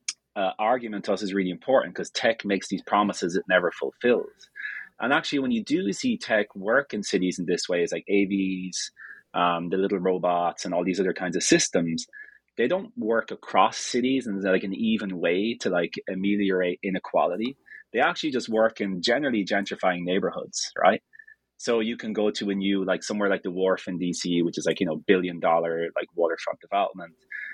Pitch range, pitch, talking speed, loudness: 90-125 Hz, 100 Hz, 195 wpm, -26 LUFS